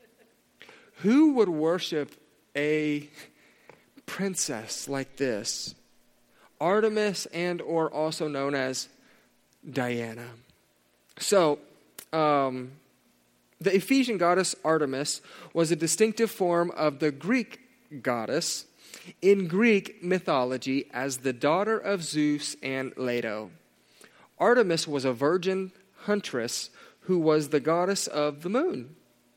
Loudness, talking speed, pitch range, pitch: -27 LUFS, 100 wpm, 140-190 Hz, 155 Hz